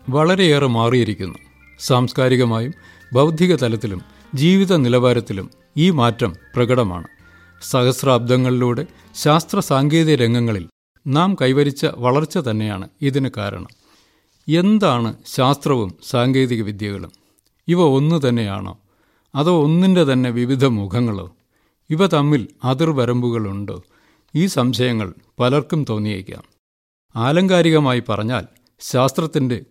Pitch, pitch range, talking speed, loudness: 125 Hz, 110-150 Hz, 85 wpm, -18 LUFS